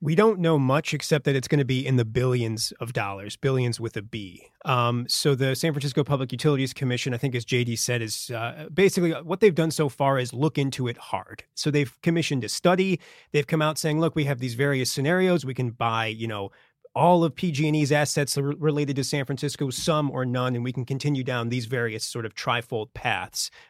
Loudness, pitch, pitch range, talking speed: -25 LUFS, 140 Hz, 125-155 Hz, 225 wpm